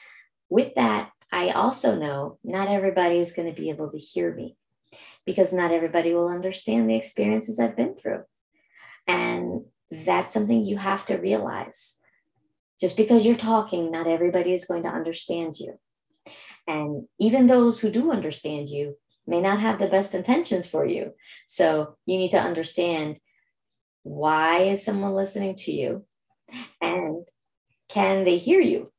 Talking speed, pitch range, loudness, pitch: 155 wpm, 155-200 Hz, -24 LUFS, 175 Hz